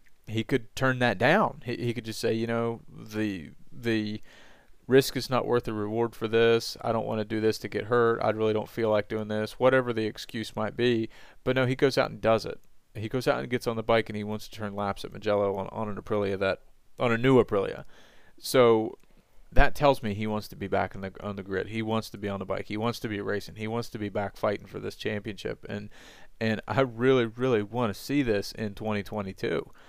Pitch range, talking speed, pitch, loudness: 105-120 Hz, 245 wpm, 110 Hz, -28 LUFS